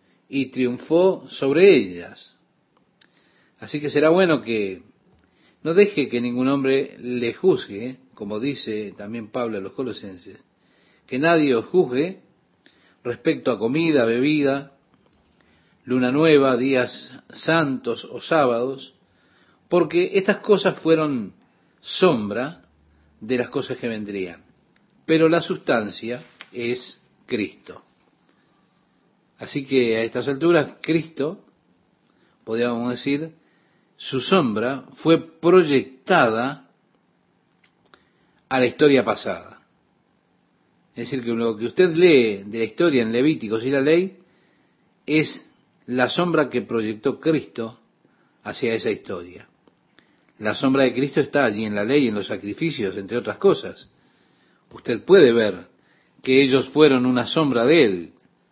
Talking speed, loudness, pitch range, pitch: 120 wpm, -21 LUFS, 115-160 Hz, 130 Hz